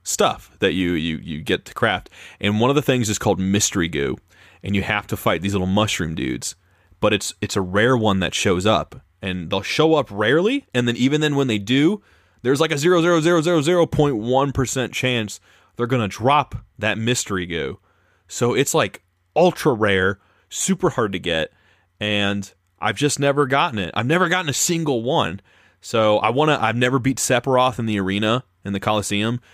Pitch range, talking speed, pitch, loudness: 95-135 Hz, 200 wpm, 110 Hz, -20 LUFS